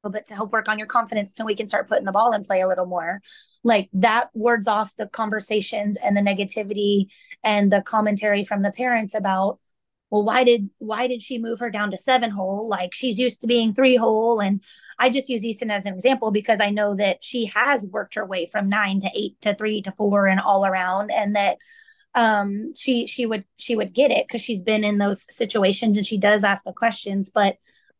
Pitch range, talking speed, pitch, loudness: 200-235 Hz, 225 wpm, 215 Hz, -22 LUFS